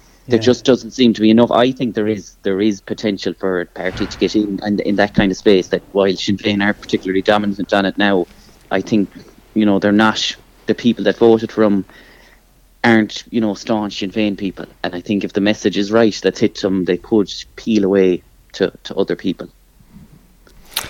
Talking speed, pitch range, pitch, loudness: 215 wpm, 100-110 Hz, 105 Hz, -16 LUFS